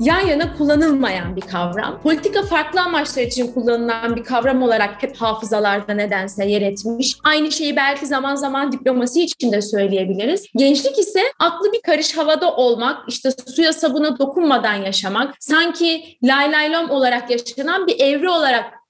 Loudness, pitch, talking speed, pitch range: -17 LUFS, 275 Hz, 145 wpm, 235-315 Hz